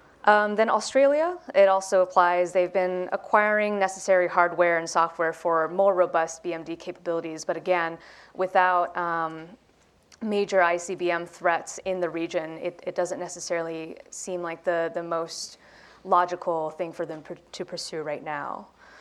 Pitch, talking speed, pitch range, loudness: 175 Hz, 145 wpm, 165-190 Hz, -25 LUFS